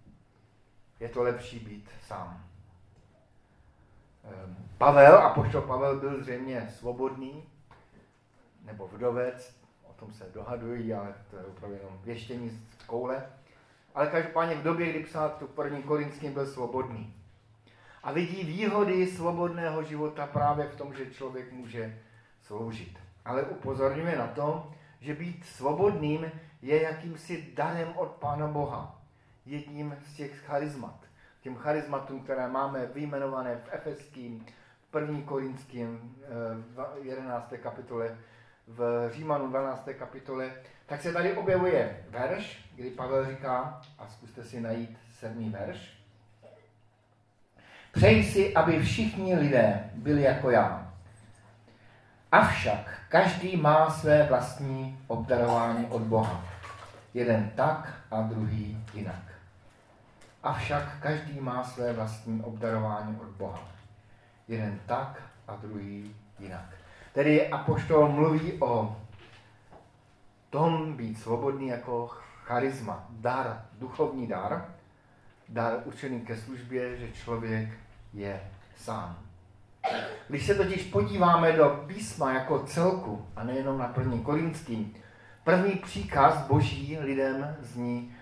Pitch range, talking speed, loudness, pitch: 110-145 Hz, 115 wpm, -29 LUFS, 120 Hz